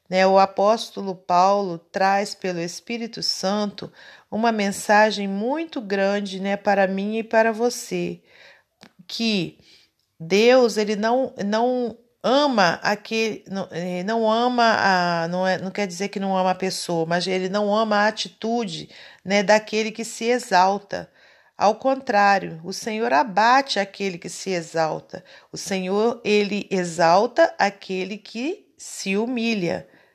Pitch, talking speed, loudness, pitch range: 205 Hz, 130 wpm, -22 LUFS, 190-225 Hz